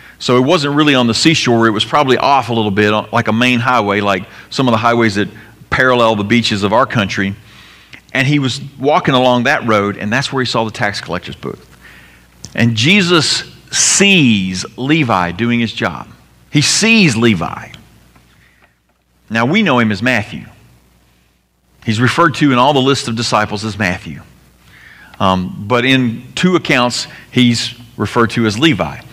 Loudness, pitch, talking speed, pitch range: -13 LUFS, 115 Hz, 170 wpm, 100-130 Hz